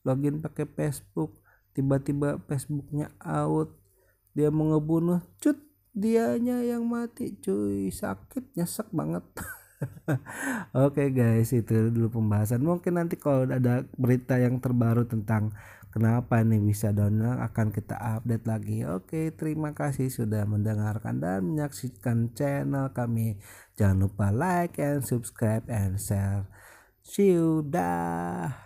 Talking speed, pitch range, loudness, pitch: 125 wpm, 110-150 Hz, -28 LUFS, 125 Hz